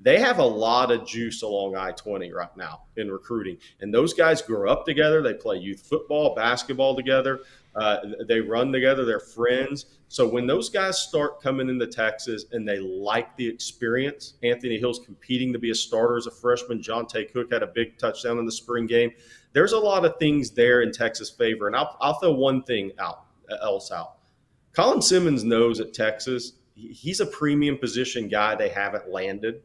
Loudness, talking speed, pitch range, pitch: -24 LUFS, 195 wpm, 115-135 Hz, 120 Hz